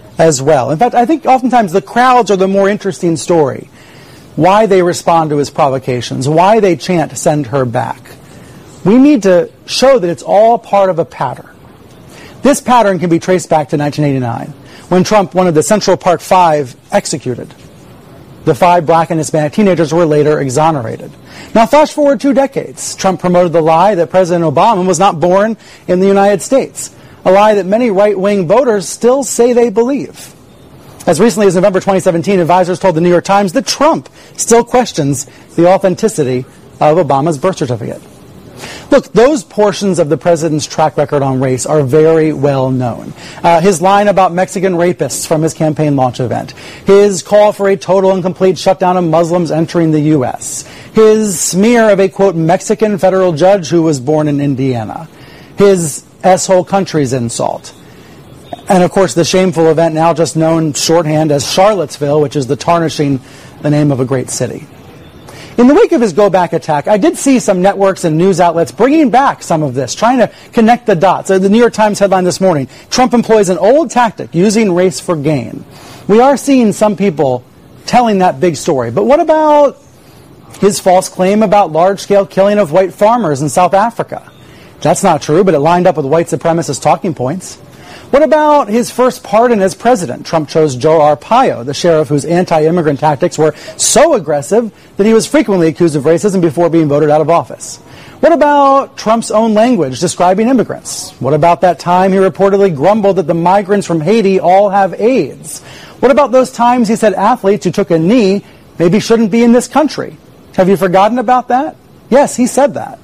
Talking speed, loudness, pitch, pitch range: 185 wpm, -10 LUFS, 185 Hz, 160-210 Hz